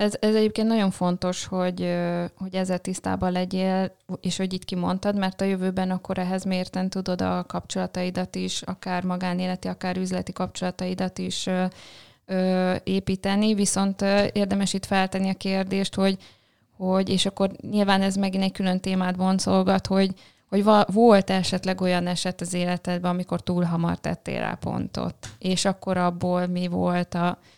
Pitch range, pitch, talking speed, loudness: 180-195 Hz, 185 Hz, 150 wpm, -25 LUFS